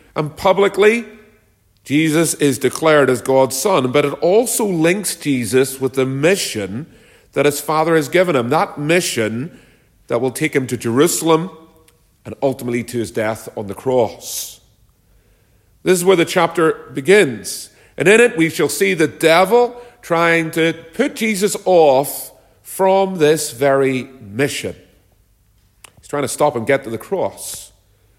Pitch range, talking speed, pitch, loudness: 120-165 Hz, 150 wpm, 145 Hz, -16 LUFS